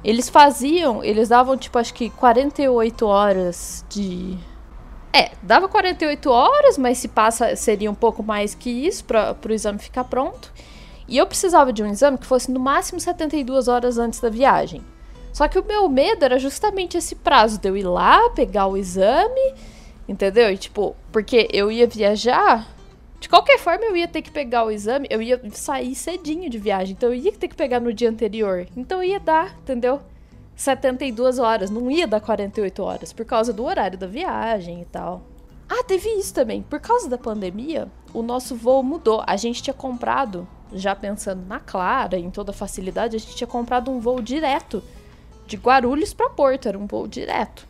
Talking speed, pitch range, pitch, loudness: 190 wpm, 215-285 Hz, 245 Hz, -20 LUFS